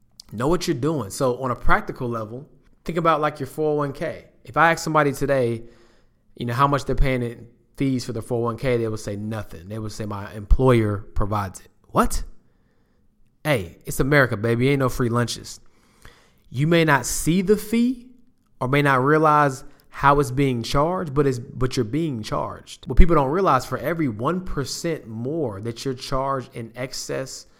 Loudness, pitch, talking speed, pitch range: -22 LUFS, 130 Hz, 185 wpm, 115-150 Hz